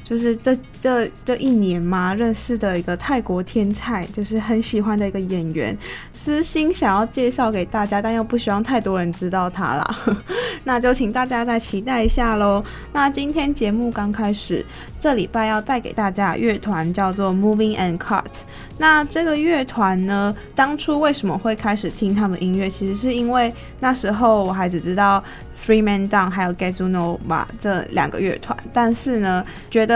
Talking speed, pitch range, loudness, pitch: 310 characters per minute, 195-245 Hz, -20 LUFS, 215 Hz